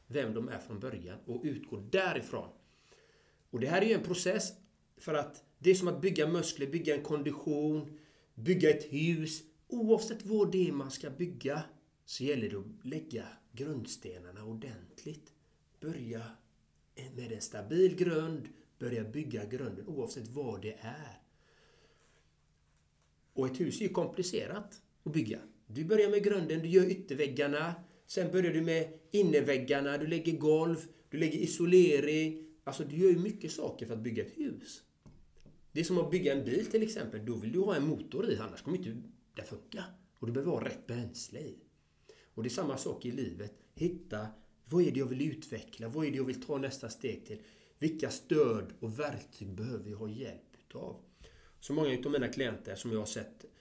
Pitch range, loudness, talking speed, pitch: 120-170 Hz, -34 LUFS, 180 wpm, 150 Hz